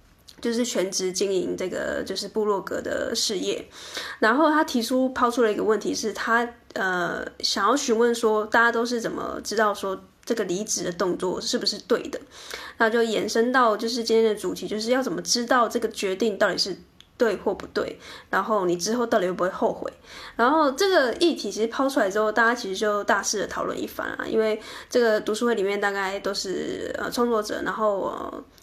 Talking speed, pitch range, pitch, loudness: 305 characters per minute, 205-240 Hz, 225 Hz, -24 LUFS